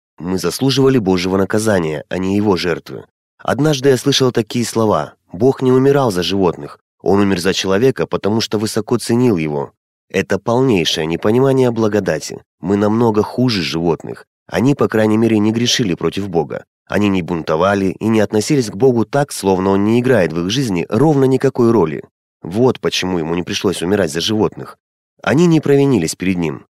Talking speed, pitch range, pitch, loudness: 170 wpm, 95-130 Hz, 110 Hz, -15 LUFS